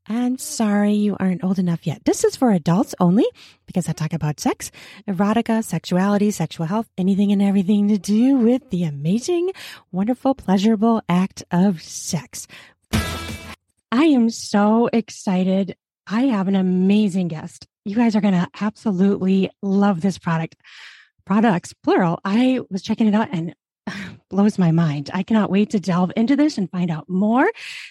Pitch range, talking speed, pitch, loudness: 180-225 Hz, 160 wpm, 200 Hz, -20 LUFS